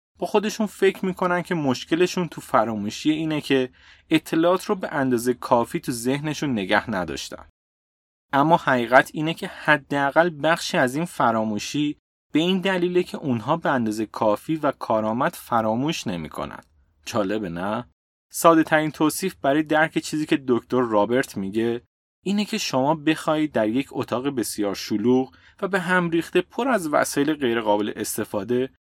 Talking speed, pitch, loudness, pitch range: 145 wpm, 140 Hz, -23 LUFS, 115-165 Hz